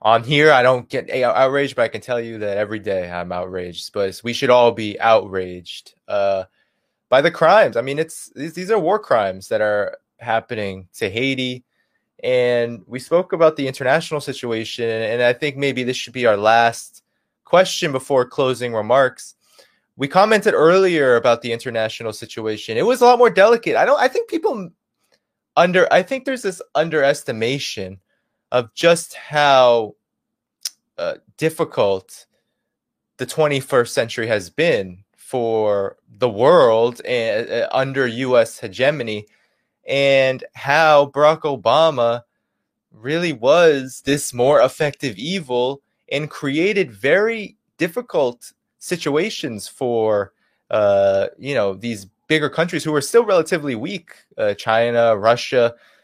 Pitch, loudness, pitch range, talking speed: 130 Hz, -18 LUFS, 115-155 Hz, 140 wpm